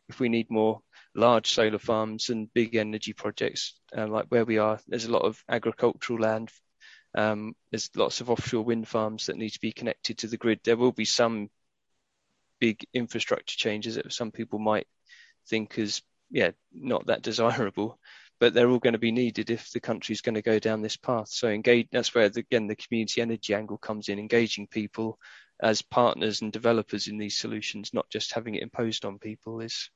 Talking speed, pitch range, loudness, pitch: 200 wpm, 110-115 Hz, -28 LUFS, 110 Hz